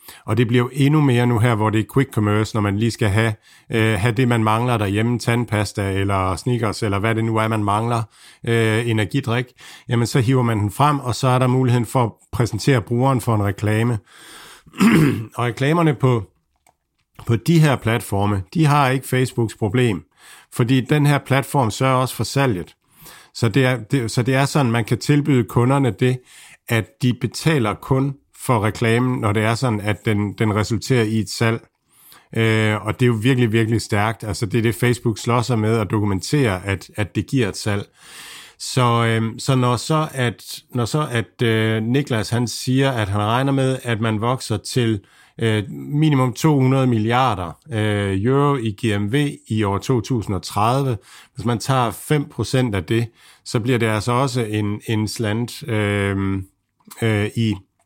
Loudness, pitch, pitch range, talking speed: -19 LUFS, 115 Hz, 110-130 Hz, 185 wpm